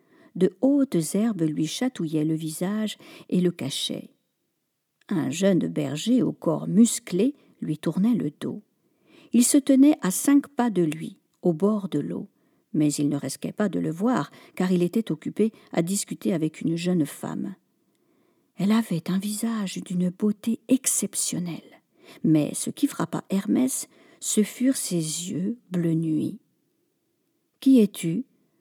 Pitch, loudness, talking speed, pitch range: 210 Hz, -25 LUFS, 145 wpm, 170-260 Hz